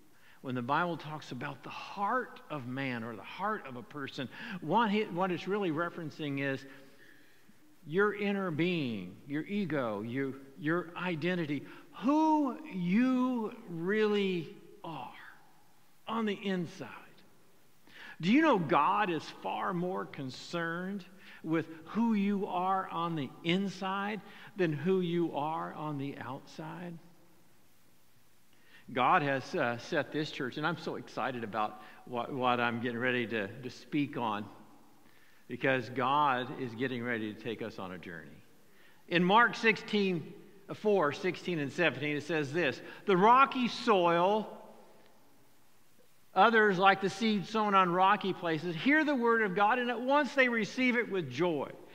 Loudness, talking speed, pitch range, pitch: -32 LUFS, 135 wpm, 140-205 Hz, 175 Hz